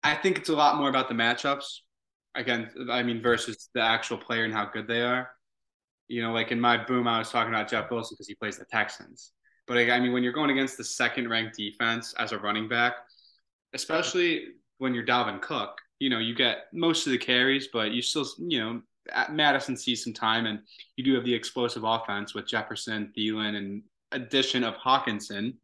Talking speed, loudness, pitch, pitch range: 205 wpm, -27 LUFS, 120 Hz, 115-130 Hz